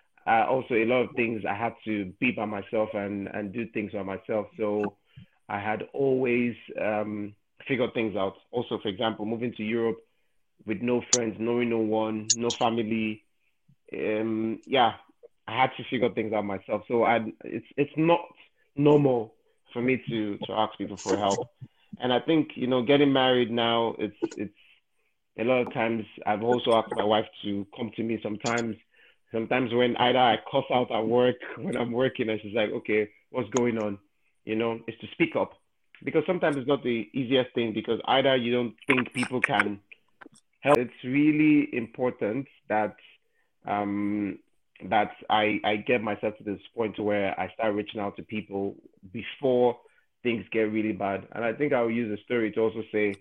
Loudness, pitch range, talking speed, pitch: -27 LUFS, 105-125 Hz, 185 wpm, 115 Hz